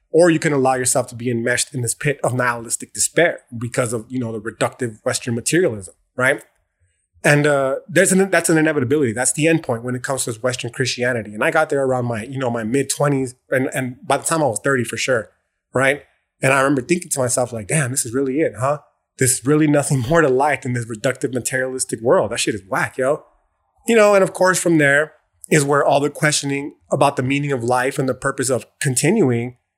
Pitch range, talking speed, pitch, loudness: 125-145 Hz, 225 wpm, 135 Hz, -18 LUFS